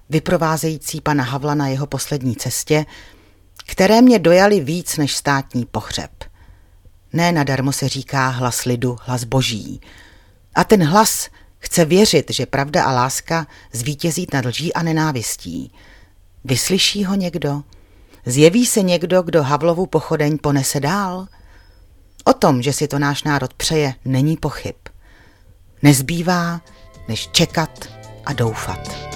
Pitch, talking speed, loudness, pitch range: 140 Hz, 130 wpm, -17 LUFS, 110-165 Hz